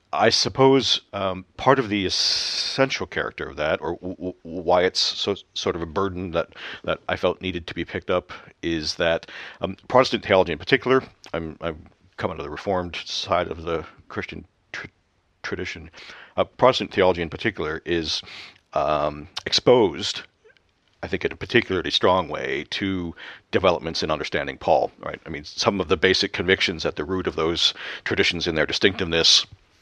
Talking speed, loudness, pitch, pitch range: 170 wpm, -23 LUFS, 90 Hz, 85-100 Hz